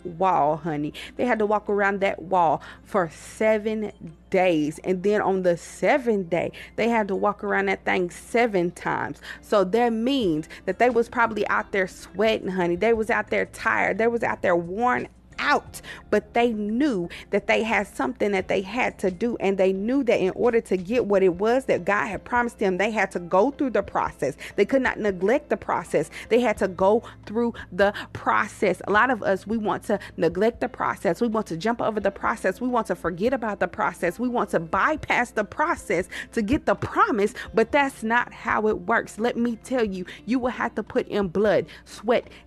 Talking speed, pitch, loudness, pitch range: 210 wpm, 210 Hz, -24 LUFS, 190-235 Hz